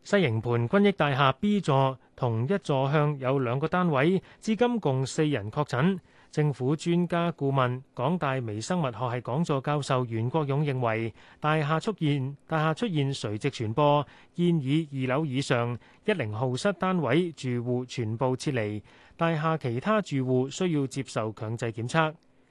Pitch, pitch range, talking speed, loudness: 140 Hz, 125-160 Hz, 245 characters per minute, -27 LUFS